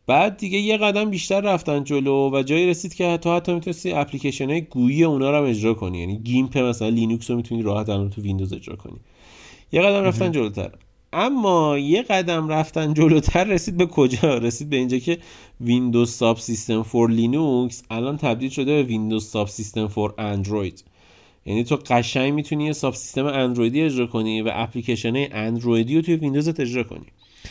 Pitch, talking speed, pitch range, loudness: 130 Hz, 175 wpm, 115-155 Hz, -21 LUFS